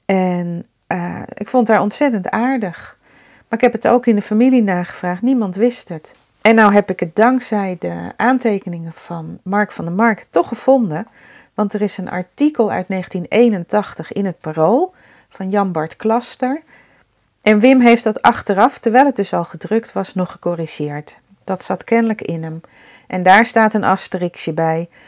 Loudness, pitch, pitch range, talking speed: -16 LUFS, 205 Hz, 175-230 Hz, 170 wpm